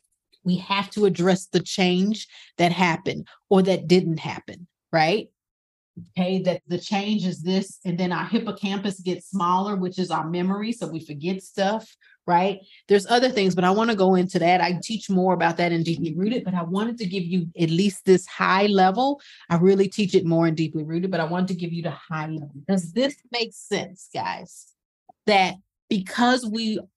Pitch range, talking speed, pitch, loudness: 175-200 Hz, 195 wpm, 185 Hz, -23 LUFS